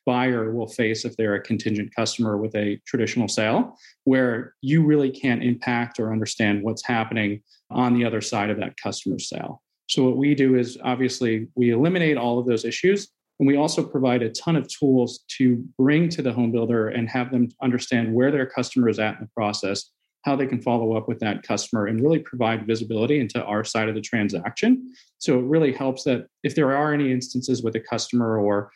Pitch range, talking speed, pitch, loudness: 110-130 Hz, 205 wpm, 120 Hz, -23 LUFS